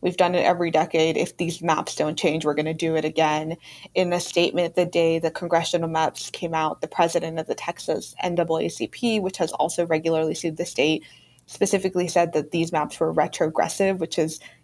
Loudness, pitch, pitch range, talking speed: -23 LUFS, 165 Hz, 160-175 Hz, 195 wpm